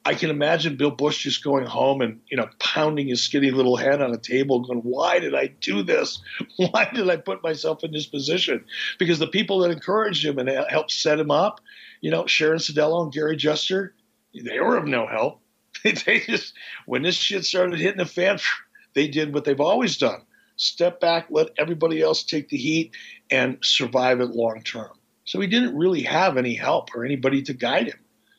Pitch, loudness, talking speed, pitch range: 155 Hz, -22 LUFS, 205 wpm, 140-180 Hz